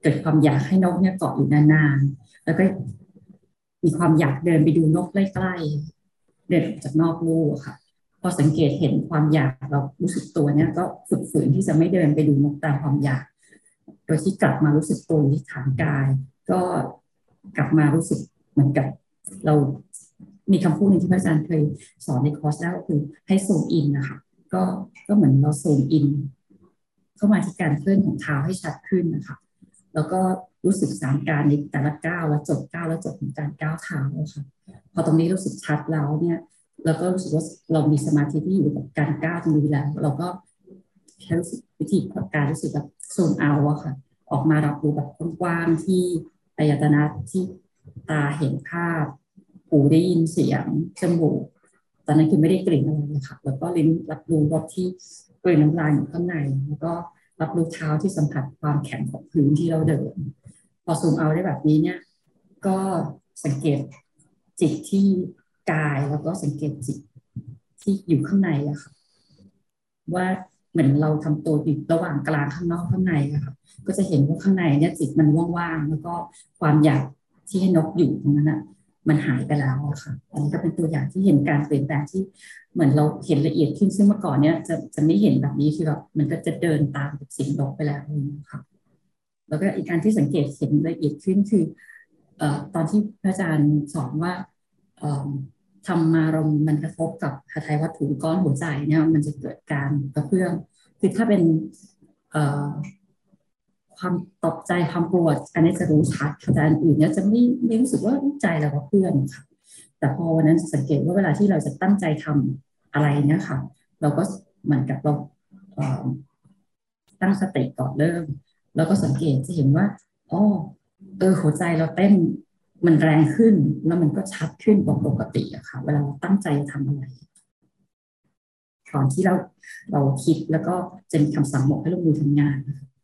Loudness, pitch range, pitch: -22 LUFS, 145-175 Hz, 155 Hz